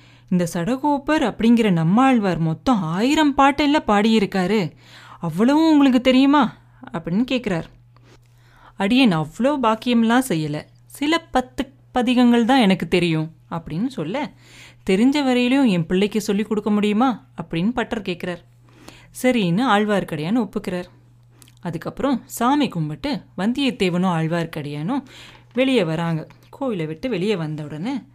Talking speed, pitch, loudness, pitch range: 105 wpm, 205 Hz, -20 LUFS, 165-255 Hz